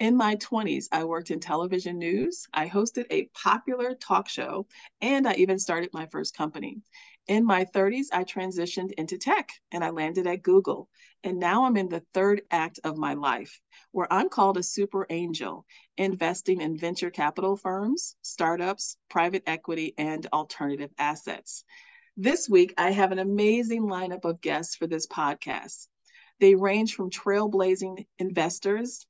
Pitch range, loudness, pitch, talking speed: 170-210 Hz, -27 LUFS, 190 Hz, 160 wpm